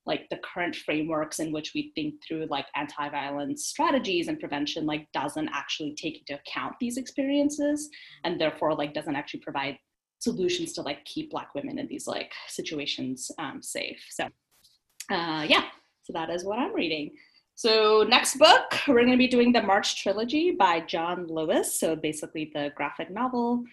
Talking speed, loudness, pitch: 170 wpm, -27 LUFS, 230 Hz